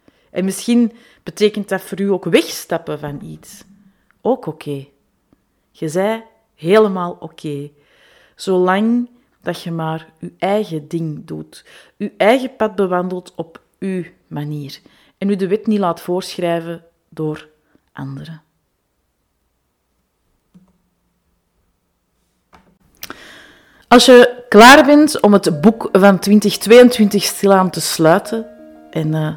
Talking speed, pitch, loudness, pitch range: 115 wpm, 185 Hz, -14 LUFS, 160-215 Hz